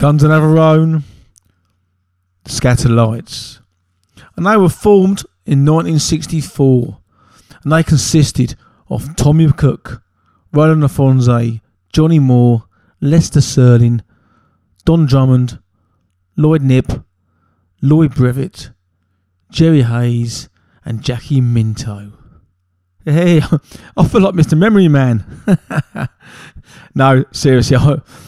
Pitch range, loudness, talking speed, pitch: 105-150 Hz, -12 LUFS, 95 wpm, 125 Hz